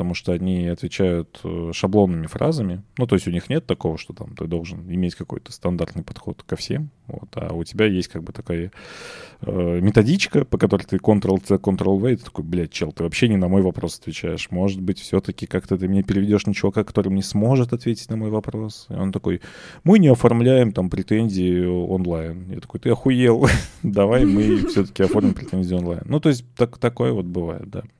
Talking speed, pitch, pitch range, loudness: 195 wpm, 100 Hz, 90-115 Hz, -21 LUFS